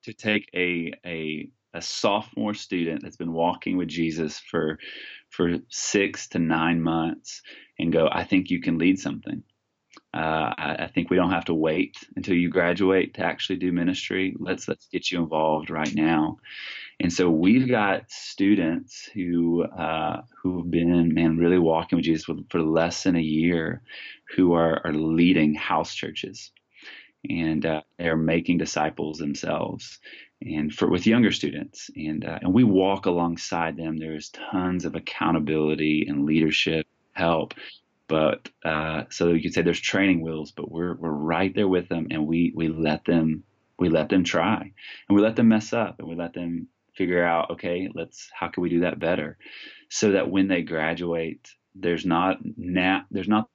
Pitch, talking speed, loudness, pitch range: 85 Hz, 175 wpm, -24 LUFS, 80-90 Hz